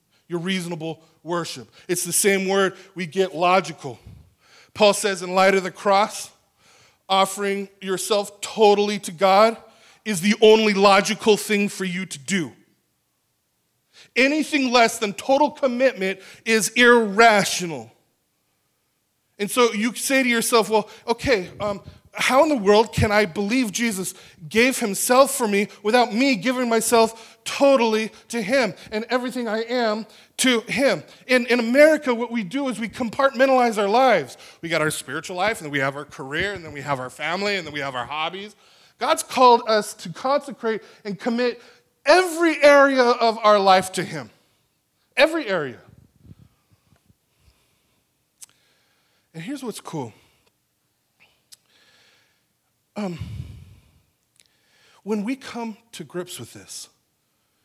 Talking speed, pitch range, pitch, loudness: 140 wpm, 180-240 Hz, 210 Hz, -20 LUFS